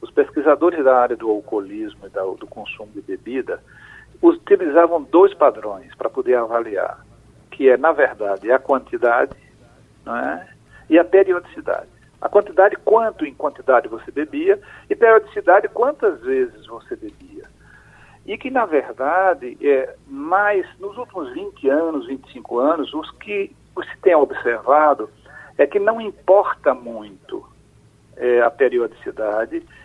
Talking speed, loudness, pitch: 130 wpm, -18 LUFS, 220 Hz